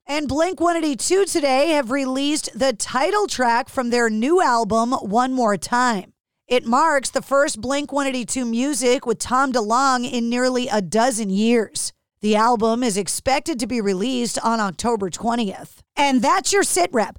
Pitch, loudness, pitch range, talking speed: 250 Hz, -20 LUFS, 230-280 Hz, 155 wpm